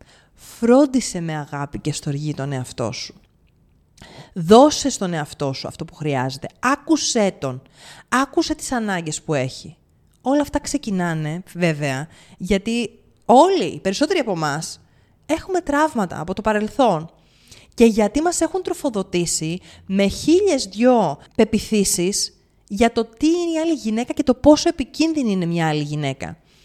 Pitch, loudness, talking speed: 200 Hz, -20 LUFS, 135 wpm